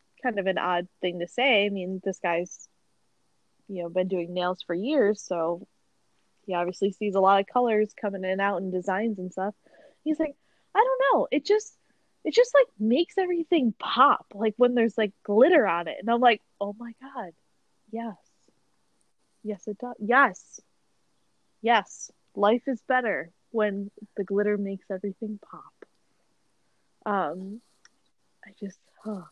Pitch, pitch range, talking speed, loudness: 210 Hz, 190-245 Hz, 160 wpm, -26 LUFS